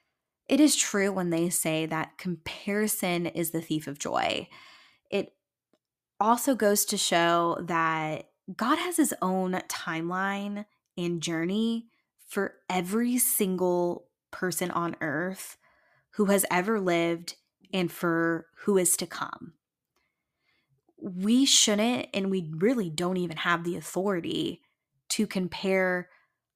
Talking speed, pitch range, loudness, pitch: 120 wpm, 170-205 Hz, -27 LUFS, 185 Hz